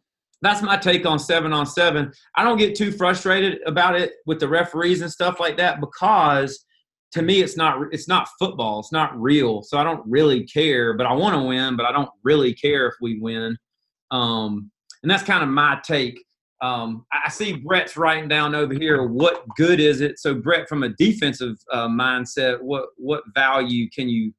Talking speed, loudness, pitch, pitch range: 200 wpm, -20 LUFS, 150 Hz, 125-175 Hz